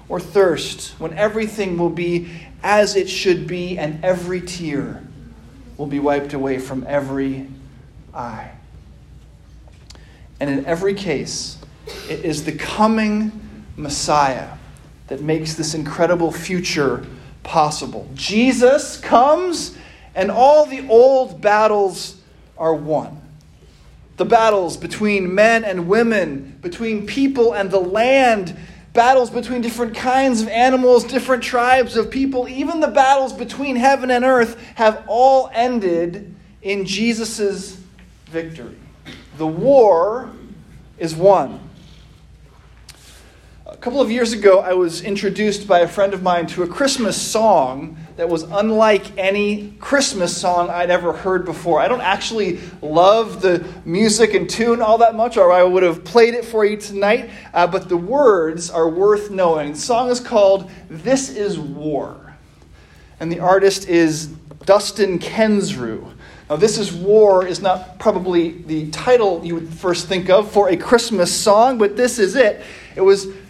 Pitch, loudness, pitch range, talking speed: 195 Hz, -17 LUFS, 170-225 Hz, 140 wpm